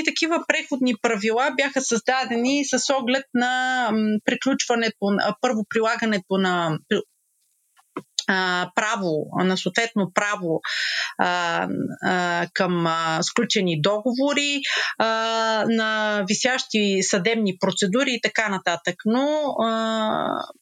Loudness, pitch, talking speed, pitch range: -22 LUFS, 225 Hz, 80 wpm, 195-255 Hz